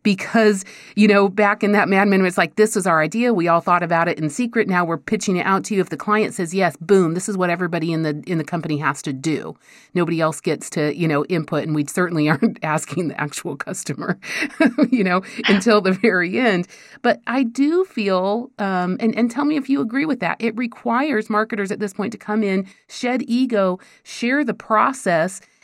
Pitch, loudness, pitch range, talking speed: 200 Hz, -19 LUFS, 170-225 Hz, 220 wpm